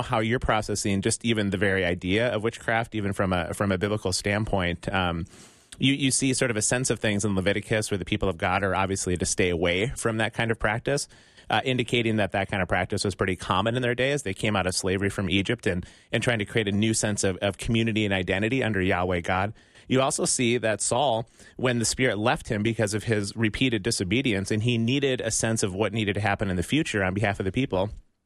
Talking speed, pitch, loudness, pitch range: 240 wpm, 105 Hz, -25 LUFS, 95-115 Hz